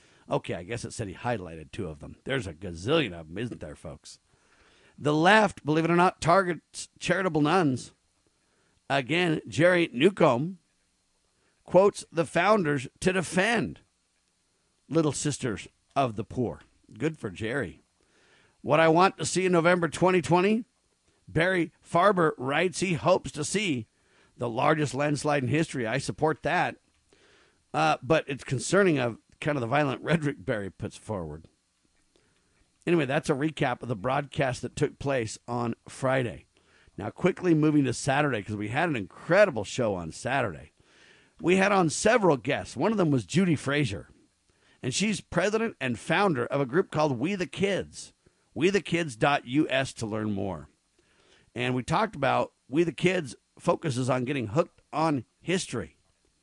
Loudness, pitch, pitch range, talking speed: -27 LUFS, 150 Hz, 120-175 Hz, 155 wpm